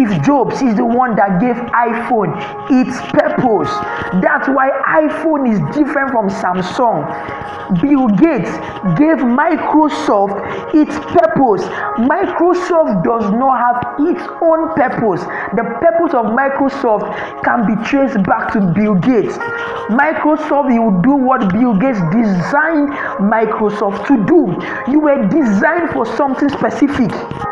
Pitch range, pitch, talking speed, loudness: 220-305 Hz, 265 Hz, 120 wpm, -14 LUFS